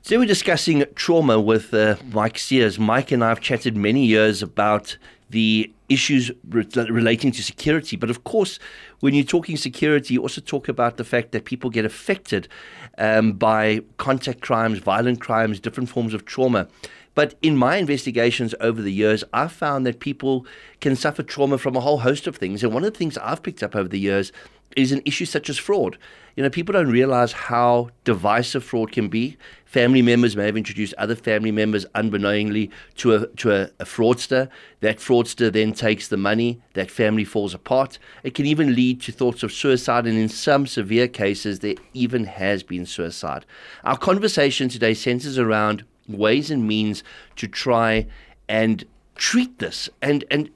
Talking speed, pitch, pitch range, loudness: 185 wpm, 120 Hz, 110-135 Hz, -21 LUFS